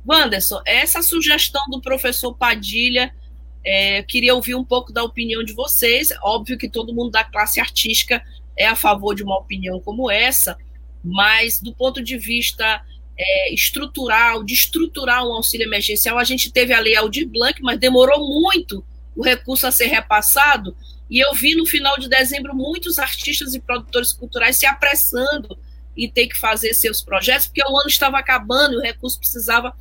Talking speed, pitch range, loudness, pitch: 175 wpm, 220-275 Hz, -16 LUFS, 245 Hz